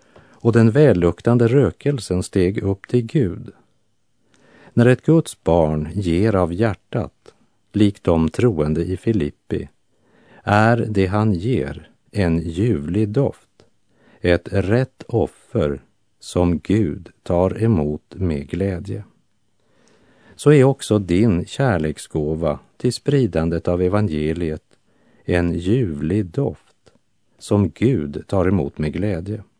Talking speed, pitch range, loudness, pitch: 110 wpm, 85-115 Hz, -19 LUFS, 100 Hz